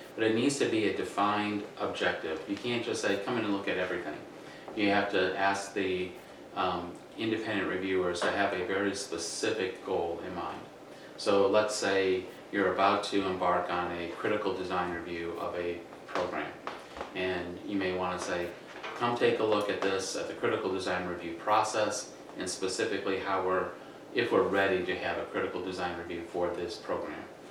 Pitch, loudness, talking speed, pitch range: 95 Hz, -31 LUFS, 180 wpm, 90-100 Hz